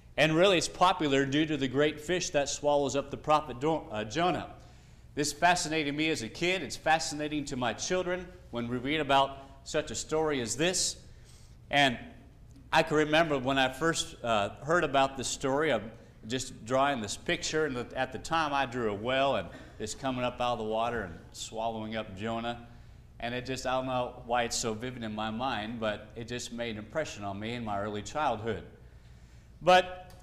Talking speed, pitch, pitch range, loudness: 200 wpm, 130 Hz, 115-155 Hz, -30 LUFS